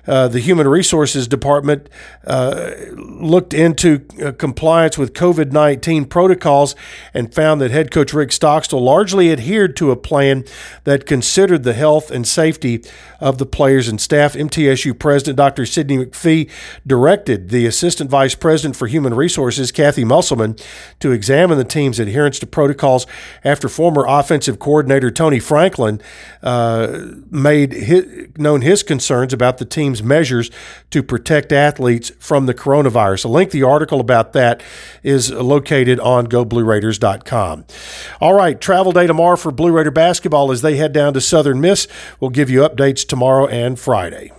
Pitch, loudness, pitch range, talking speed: 140 Hz, -14 LUFS, 130-155 Hz, 150 wpm